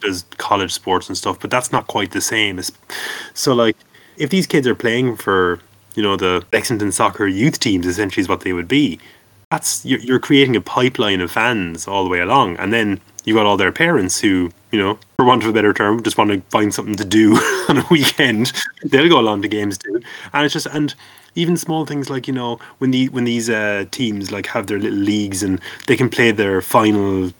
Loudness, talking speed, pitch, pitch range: -17 LUFS, 225 wpm, 110 Hz, 100-130 Hz